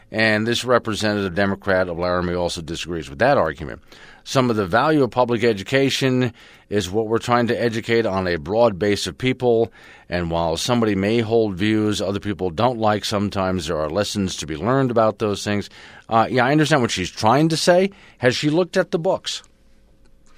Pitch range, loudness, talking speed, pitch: 95-120 Hz, -20 LUFS, 190 wpm, 110 Hz